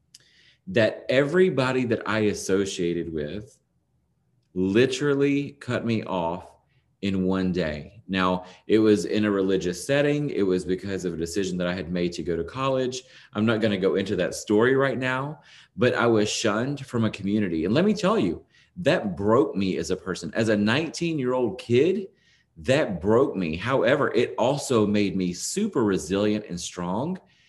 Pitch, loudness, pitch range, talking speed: 110 Hz, -24 LUFS, 95-135 Hz, 175 wpm